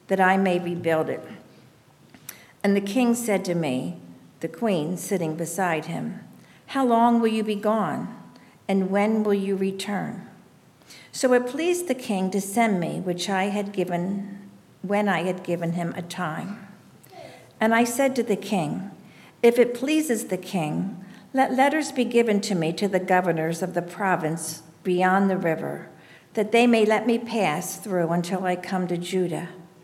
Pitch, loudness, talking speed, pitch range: 195 Hz, -24 LUFS, 170 wpm, 175-215 Hz